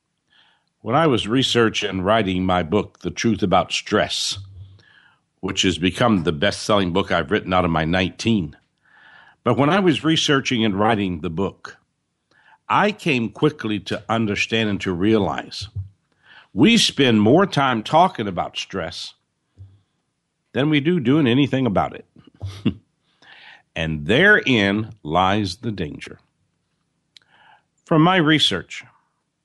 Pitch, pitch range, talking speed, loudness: 110 Hz, 95-140 Hz, 130 wpm, -19 LUFS